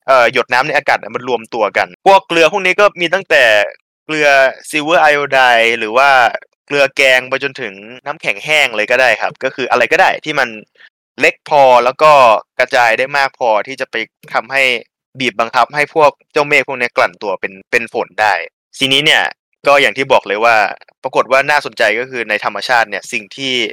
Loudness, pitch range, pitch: -12 LUFS, 125-155 Hz, 140 Hz